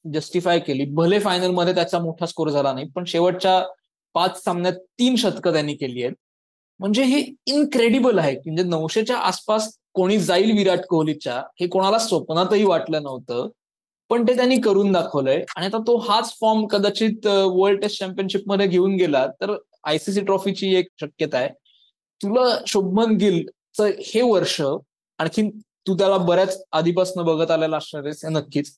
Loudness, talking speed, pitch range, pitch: -21 LUFS, 150 wpm, 165-210 Hz, 185 Hz